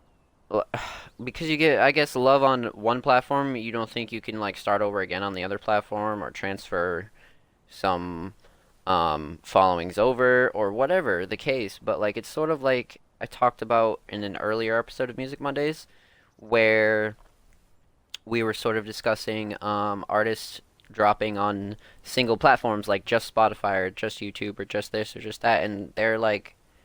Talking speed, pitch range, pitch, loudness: 170 wpm, 100-120 Hz, 110 Hz, -25 LUFS